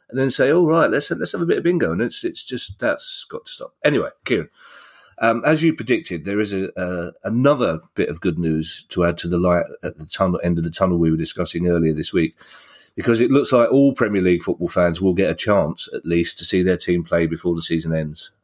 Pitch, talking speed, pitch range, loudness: 90 Hz, 255 wpm, 85-120 Hz, -20 LUFS